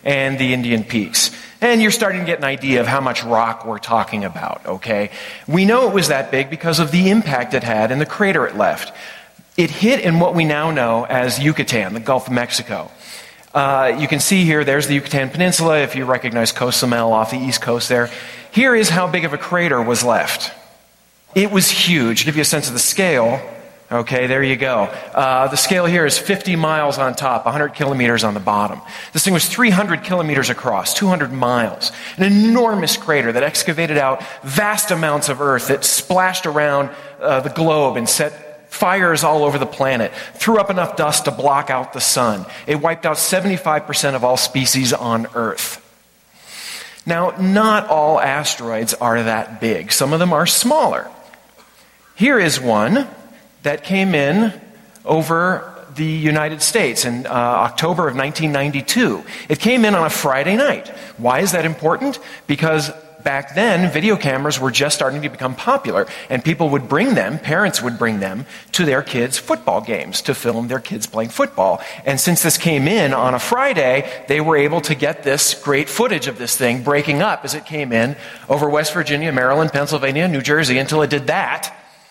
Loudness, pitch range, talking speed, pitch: -16 LUFS, 130-170 Hz, 190 wpm, 145 Hz